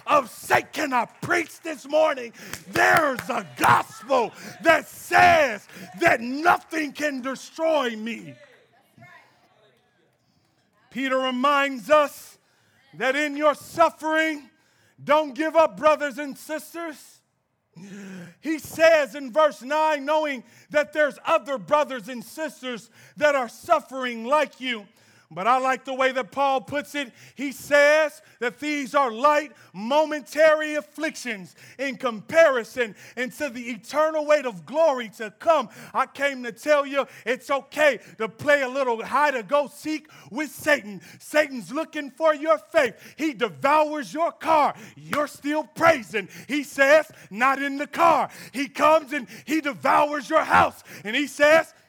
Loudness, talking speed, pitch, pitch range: -23 LUFS, 135 wpm, 285 Hz, 250-305 Hz